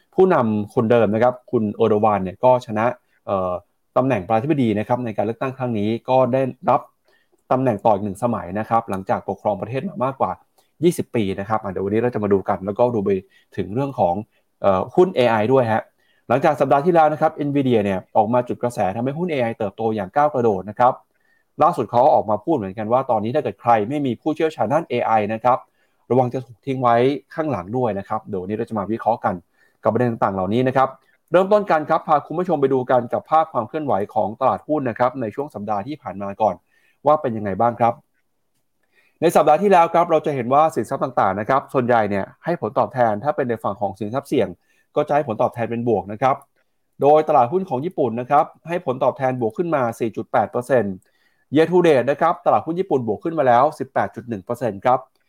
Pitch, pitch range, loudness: 125 Hz, 110-145 Hz, -20 LUFS